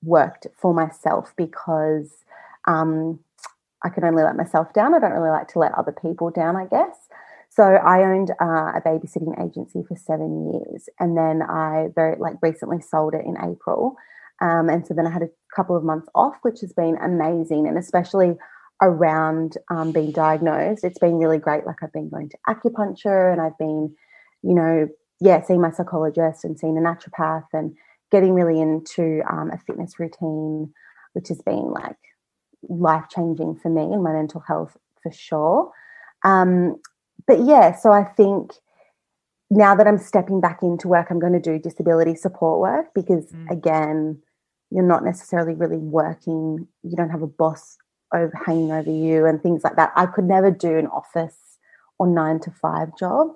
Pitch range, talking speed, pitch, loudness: 160-180 Hz, 180 wpm, 165 Hz, -20 LUFS